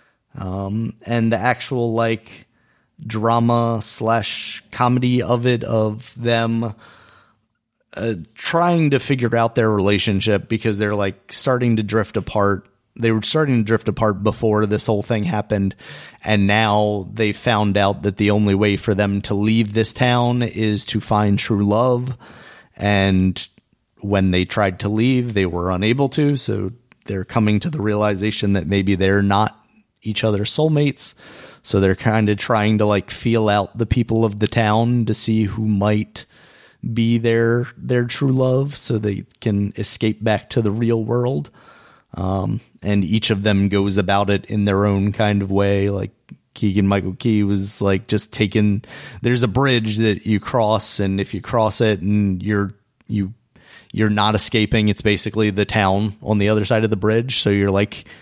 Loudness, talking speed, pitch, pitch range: -19 LUFS, 170 wpm, 110 Hz, 100-115 Hz